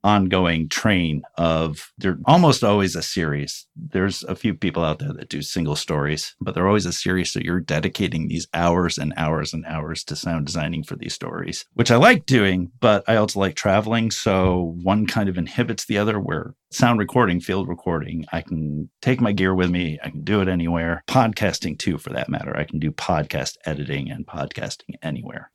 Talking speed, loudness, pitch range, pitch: 195 wpm, -22 LUFS, 80-105 Hz, 90 Hz